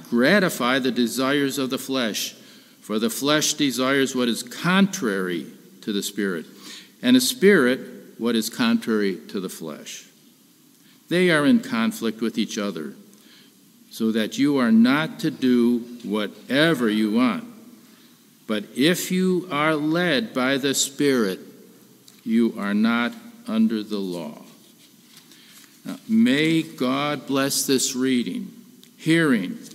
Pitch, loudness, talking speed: 145 Hz, -22 LUFS, 125 wpm